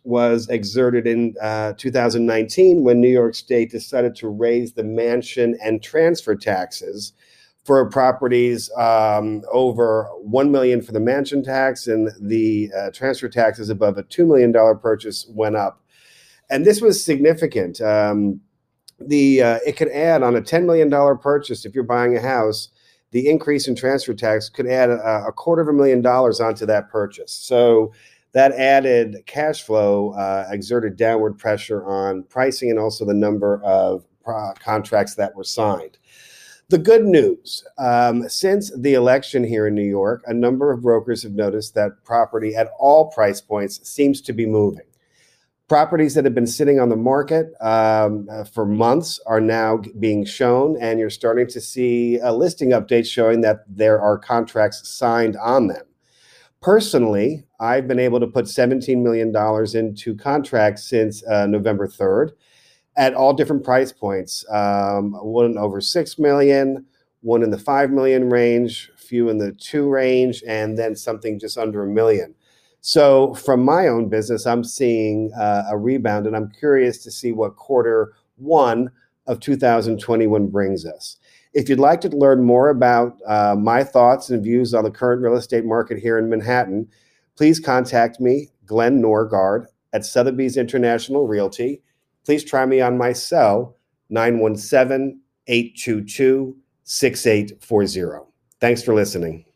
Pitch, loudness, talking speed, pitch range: 120 Hz, -18 LUFS, 160 wpm, 110-130 Hz